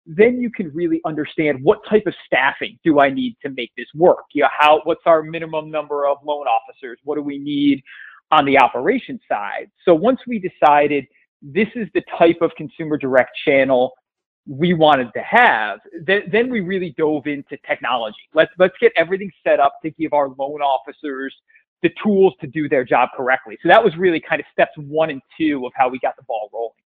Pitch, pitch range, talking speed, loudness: 155 Hz, 145-185 Hz, 205 wpm, -18 LUFS